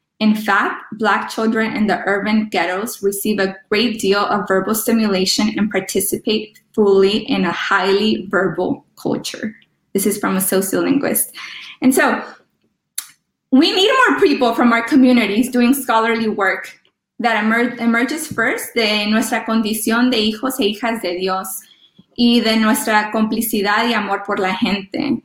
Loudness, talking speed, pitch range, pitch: -16 LUFS, 145 wpm, 200-235 Hz, 220 Hz